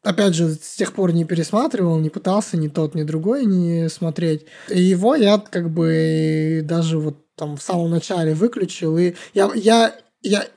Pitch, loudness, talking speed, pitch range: 170 Hz, -19 LUFS, 175 wpm, 160-200 Hz